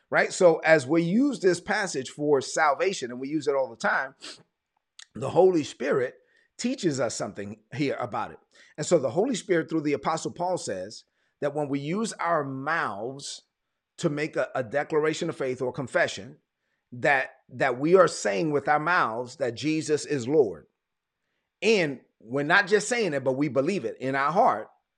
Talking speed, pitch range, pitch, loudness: 180 wpm, 140-185 Hz, 155 Hz, -26 LUFS